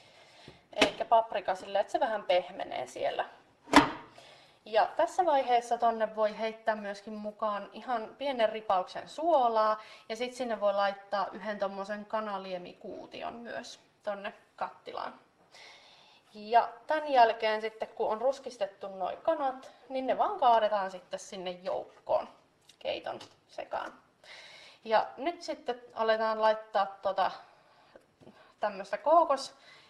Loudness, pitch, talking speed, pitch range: -31 LUFS, 220 Hz, 115 wpm, 200-250 Hz